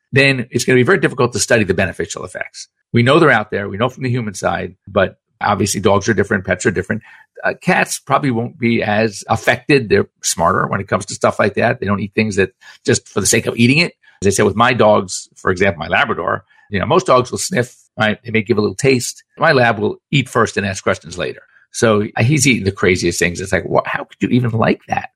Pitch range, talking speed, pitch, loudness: 105-125 Hz, 255 wpm, 115 Hz, -16 LUFS